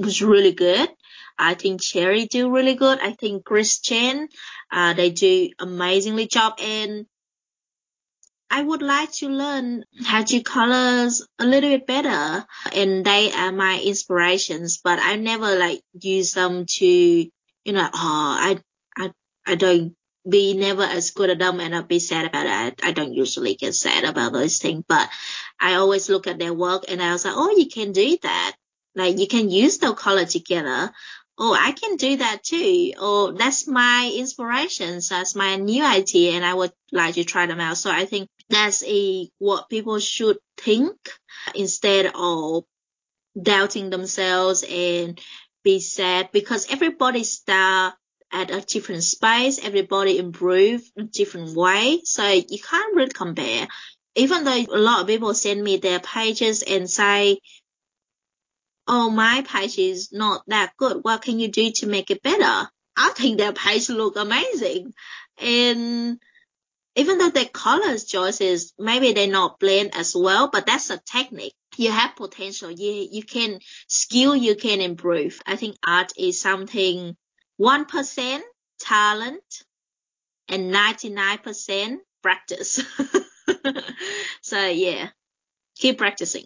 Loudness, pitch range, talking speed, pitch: -20 LUFS, 185-250 Hz, 155 wpm, 205 Hz